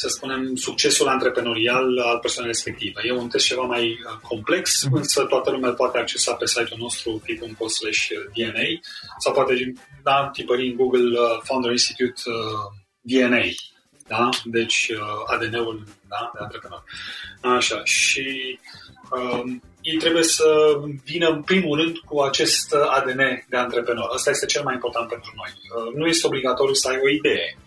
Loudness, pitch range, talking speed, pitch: -21 LUFS, 115-135 Hz, 145 wpm, 125 Hz